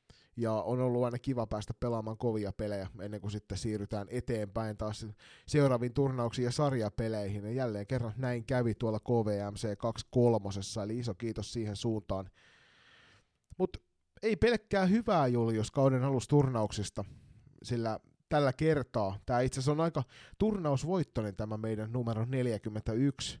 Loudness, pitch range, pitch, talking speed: -33 LUFS, 110-130 Hz, 115 Hz, 130 wpm